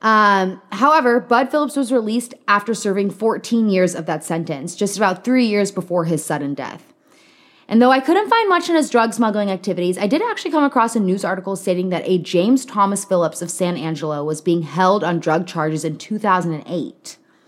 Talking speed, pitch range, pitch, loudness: 195 wpm, 175-245 Hz, 200 Hz, -18 LUFS